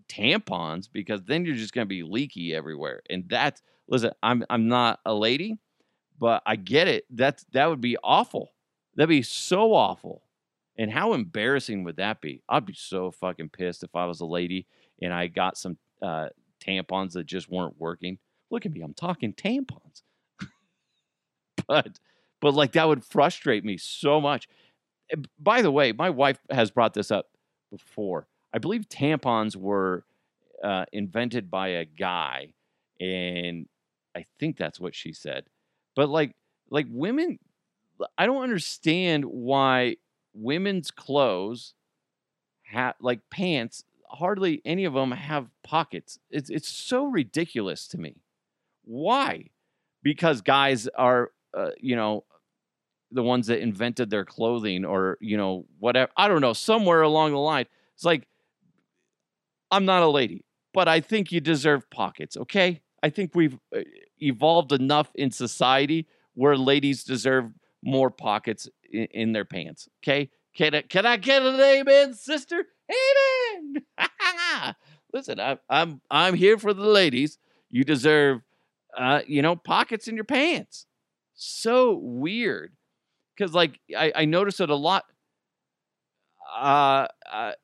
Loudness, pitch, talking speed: -25 LUFS, 140 Hz, 145 wpm